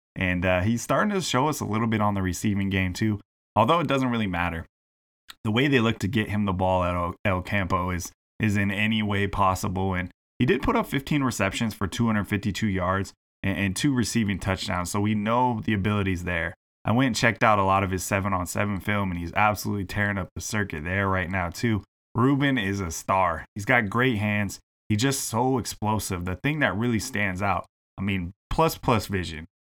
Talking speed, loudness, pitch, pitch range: 215 wpm, -25 LUFS, 105 Hz, 95-115 Hz